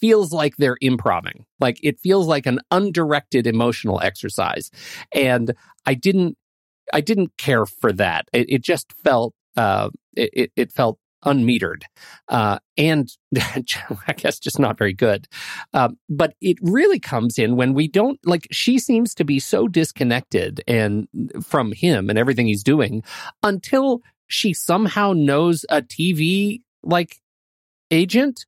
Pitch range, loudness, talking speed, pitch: 125-195 Hz, -20 LUFS, 145 wpm, 155 Hz